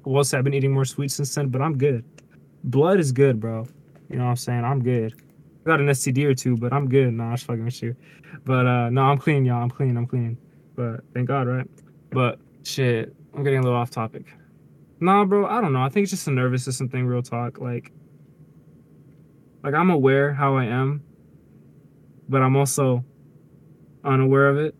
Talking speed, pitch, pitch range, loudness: 215 wpm, 135 Hz, 125-145 Hz, -22 LUFS